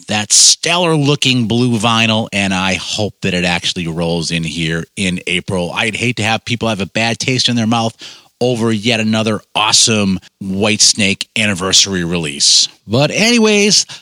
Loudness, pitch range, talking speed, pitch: -13 LUFS, 95-120 Hz, 165 wpm, 110 Hz